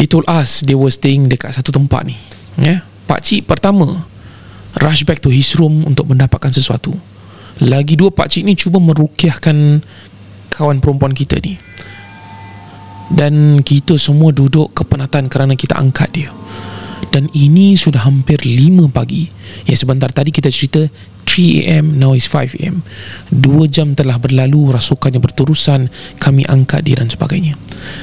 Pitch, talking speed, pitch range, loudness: 140 Hz, 150 wpm, 125-155 Hz, -11 LUFS